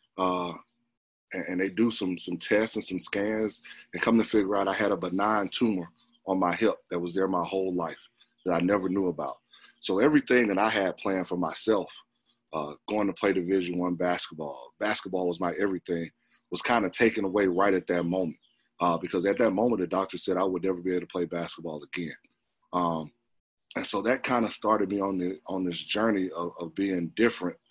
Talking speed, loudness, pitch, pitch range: 210 wpm, -28 LUFS, 95 Hz, 90-100 Hz